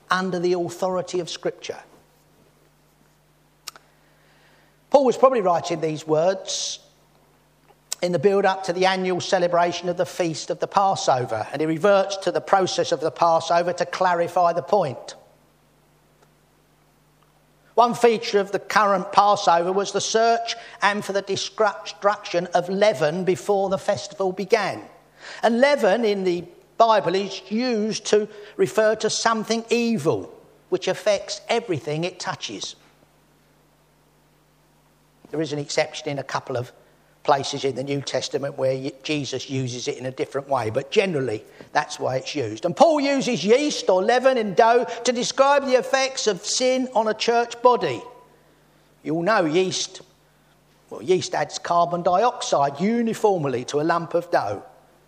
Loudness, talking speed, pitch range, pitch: -22 LUFS, 145 wpm, 170-225 Hz, 195 Hz